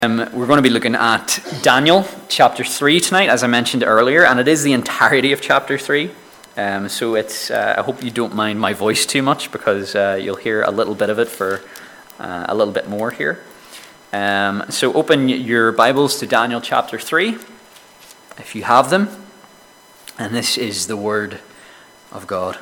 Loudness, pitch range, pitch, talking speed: -16 LUFS, 110-140 Hz, 120 Hz, 190 wpm